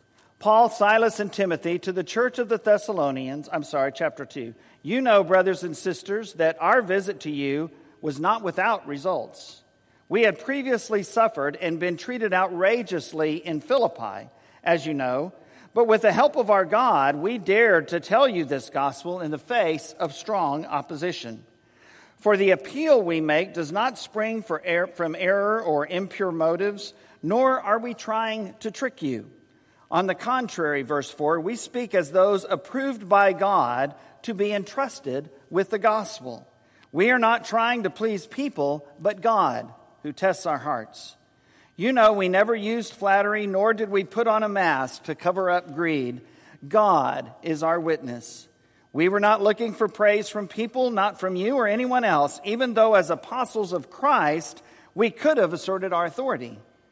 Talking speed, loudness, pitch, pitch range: 170 wpm, -23 LUFS, 195 Hz, 165-220 Hz